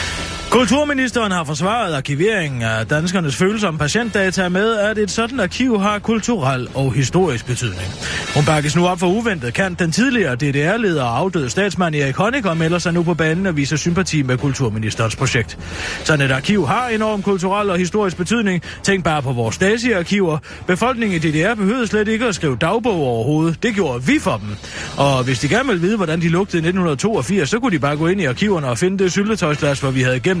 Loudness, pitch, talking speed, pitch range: -17 LUFS, 180 Hz, 200 wpm, 140-205 Hz